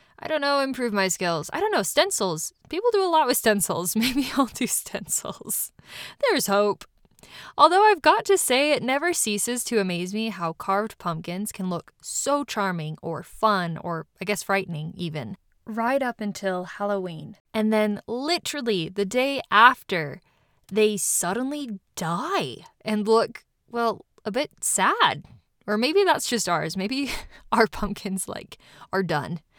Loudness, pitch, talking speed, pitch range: -24 LUFS, 210 Hz, 155 wpm, 185-260 Hz